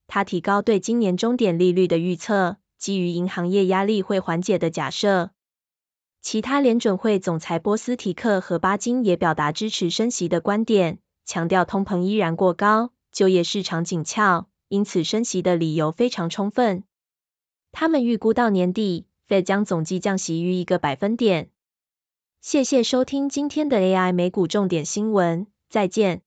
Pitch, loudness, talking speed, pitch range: 195 Hz, -22 LUFS, 255 characters per minute, 175-215 Hz